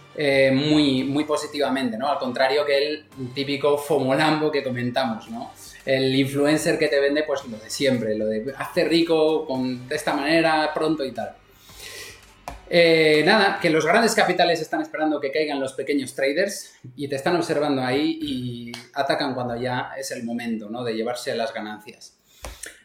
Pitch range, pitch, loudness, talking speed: 130-155 Hz, 140 Hz, -22 LUFS, 170 wpm